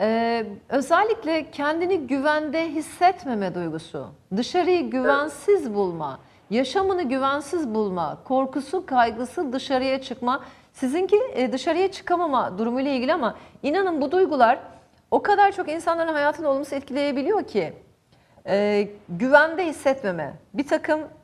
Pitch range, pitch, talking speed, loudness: 250-335 Hz, 285 Hz, 105 wpm, -23 LUFS